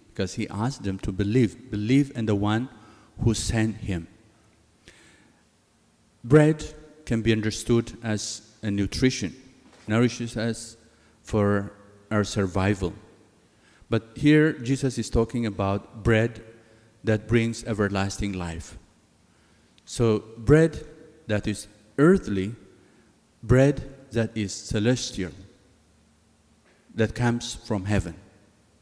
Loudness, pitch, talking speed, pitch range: -25 LUFS, 110 Hz, 100 wpm, 100-115 Hz